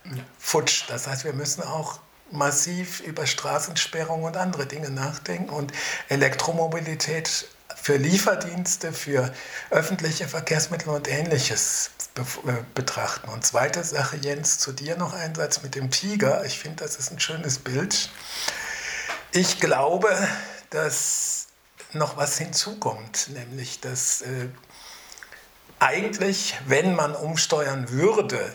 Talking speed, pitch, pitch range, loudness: 120 wpm, 150 Hz, 135-170 Hz, -25 LUFS